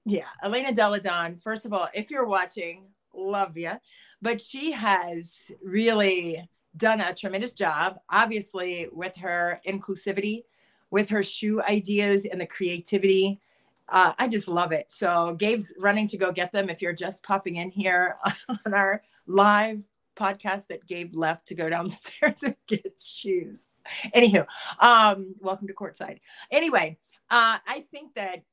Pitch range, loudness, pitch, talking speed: 180-215 Hz, -25 LUFS, 195 Hz, 150 wpm